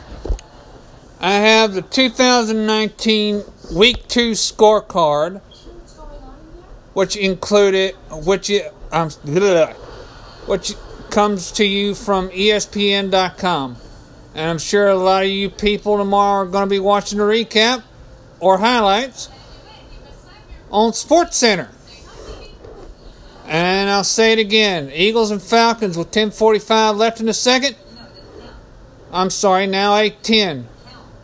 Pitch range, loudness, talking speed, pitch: 185-220 Hz, -16 LUFS, 105 wpm, 200 Hz